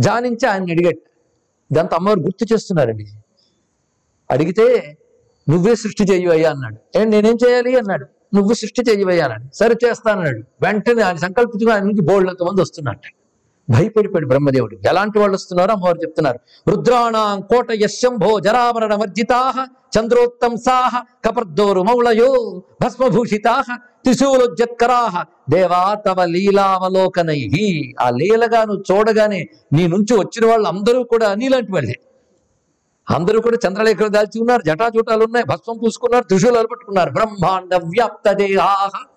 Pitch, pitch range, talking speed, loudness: 210 Hz, 180-235 Hz, 115 wpm, -16 LUFS